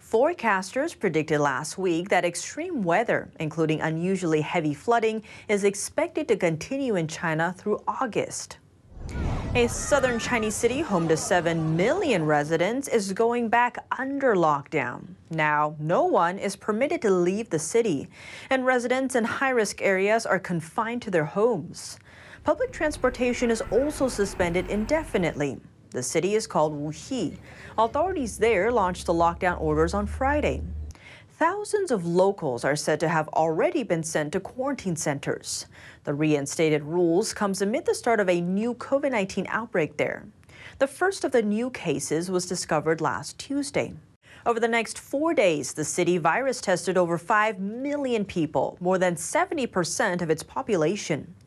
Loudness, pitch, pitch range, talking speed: -25 LUFS, 190 Hz, 160-240 Hz, 150 wpm